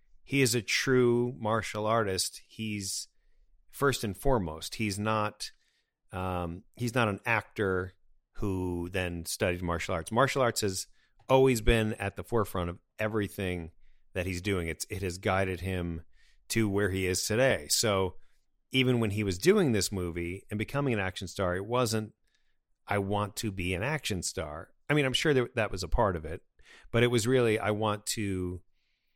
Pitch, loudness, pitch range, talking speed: 100 Hz, -30 LUFS, 90-115 Hz, 175 wpm